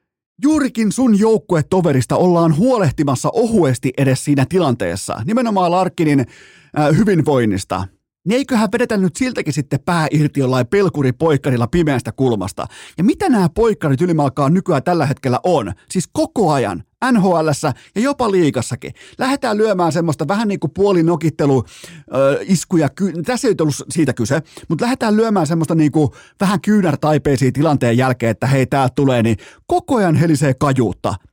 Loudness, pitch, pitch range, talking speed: -16 LUFS, 160 Hz, 135-195 Hz, 140 wpm